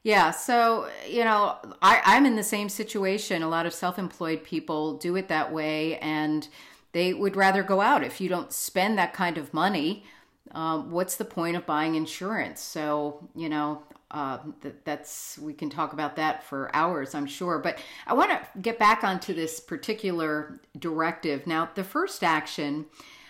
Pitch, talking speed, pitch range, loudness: 165 Hz, 180 wpm, 155-195 Hz, -27 LUFS